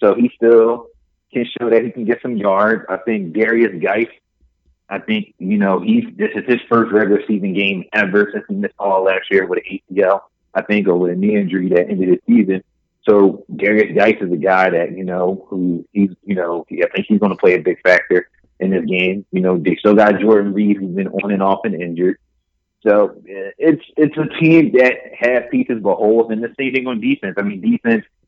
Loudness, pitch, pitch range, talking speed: -16 LUFS, 105 Hz, 95-125 Hz, 225 wpm